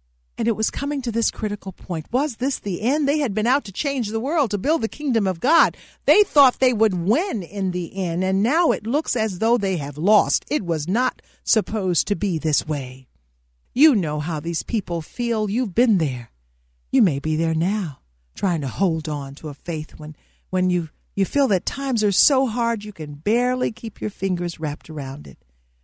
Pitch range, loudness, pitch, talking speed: 155-235 Hz, -22 LUFS, 195 Hz, 210 wpm